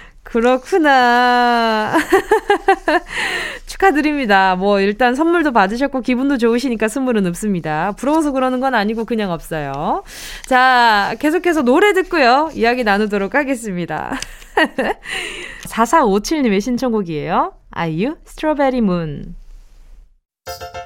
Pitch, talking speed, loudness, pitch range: 245 Hz, 270 characters per minute, -16 LUFS, 200-310 Hz